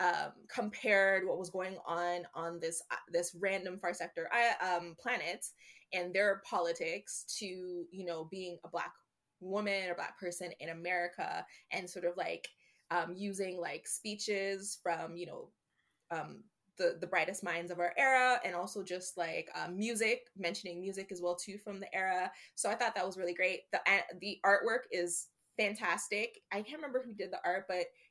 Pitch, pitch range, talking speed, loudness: 185 Hz, 175-205 Hz, 180 wpm, -36 LUFS